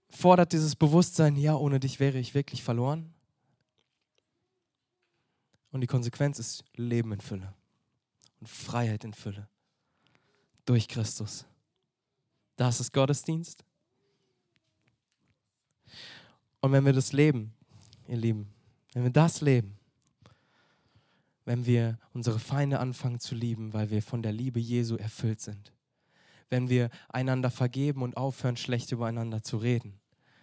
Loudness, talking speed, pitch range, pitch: -29 LUFS, 120 wpm, 115-140 Hz, 125 Hz